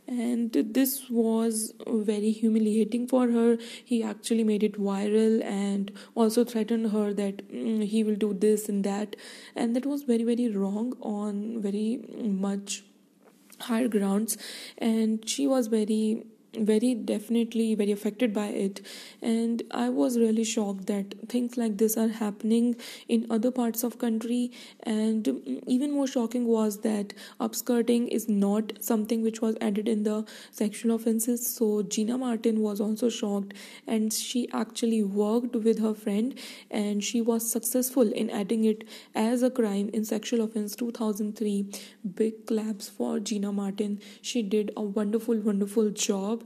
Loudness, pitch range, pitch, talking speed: -28 LUFS, 215-235 Hz, 225 Hz, 150 wpm